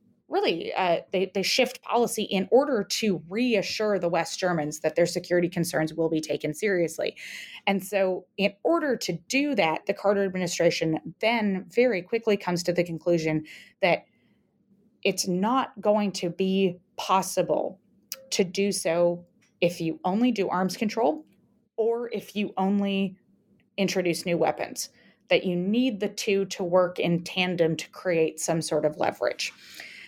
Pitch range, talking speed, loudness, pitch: 175-215 Hz, 150 wpm, -26 LUFS, 195 Hz